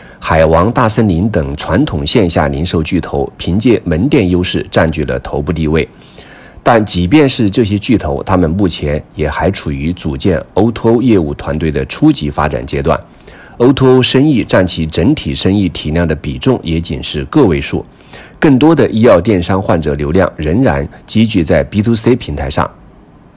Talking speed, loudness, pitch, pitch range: 255 characters per minute, -12 LUFS, 85 Hz, 75-110 Hz